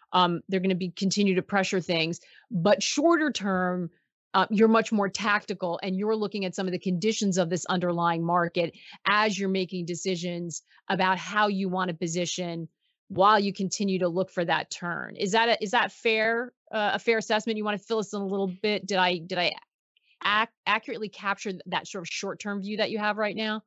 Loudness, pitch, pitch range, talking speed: -27 LUFS, 195 Hz, 180-215 Hz, 215 wpm